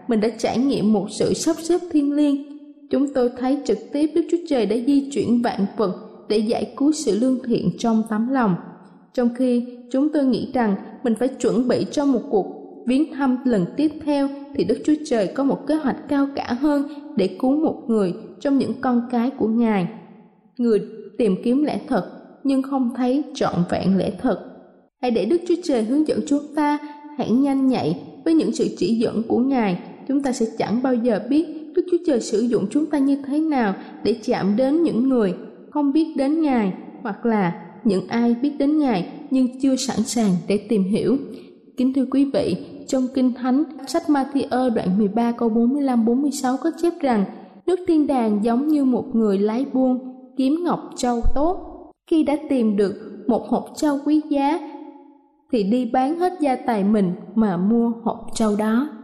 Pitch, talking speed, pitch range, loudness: 255 Hz, 195 wpm, 225-285 Hz, -21 LUFS